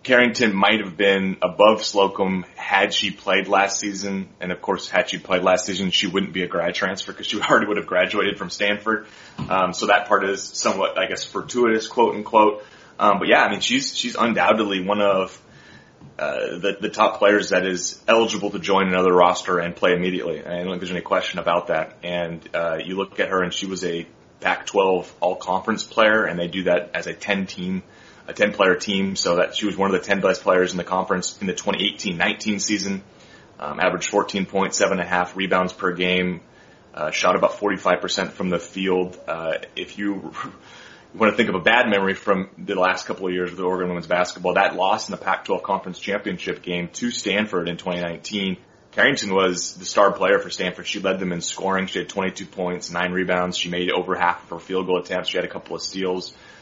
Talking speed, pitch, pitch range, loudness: 210 wpm, 95 Hz, 90-100 Hz, -21 LUFS